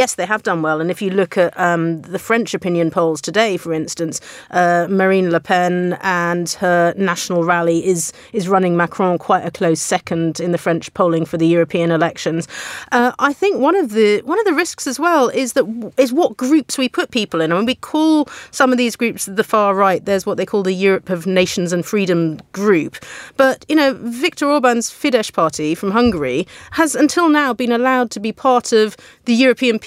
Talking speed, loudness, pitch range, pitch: 210 wpm, -16 LUFS, 175-250 Hz, 195 Hz